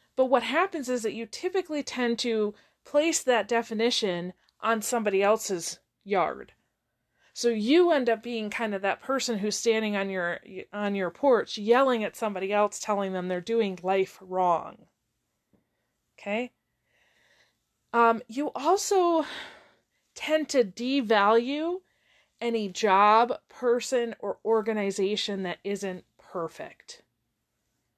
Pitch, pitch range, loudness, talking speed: 225 Hz, 205-260 Hz, -27 LUFS, 120 wpm